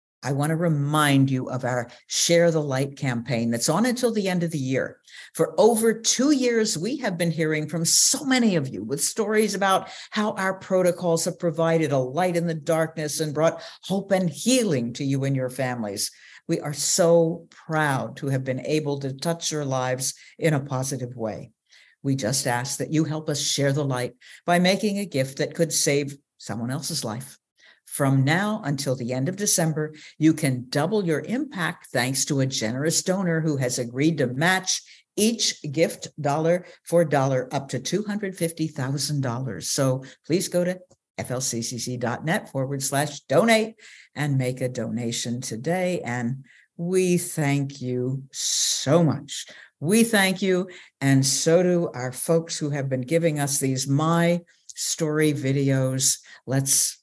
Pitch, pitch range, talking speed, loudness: 150 Hz, 130-175 Hz, 165 wpm, -23 LUFS